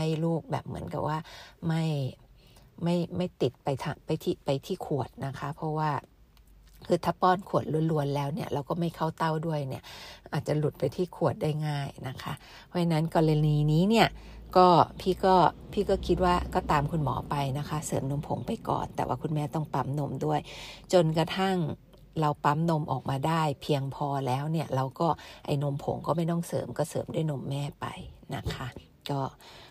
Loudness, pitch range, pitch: -29 LUFS, 140-170 Hz, 150 Hz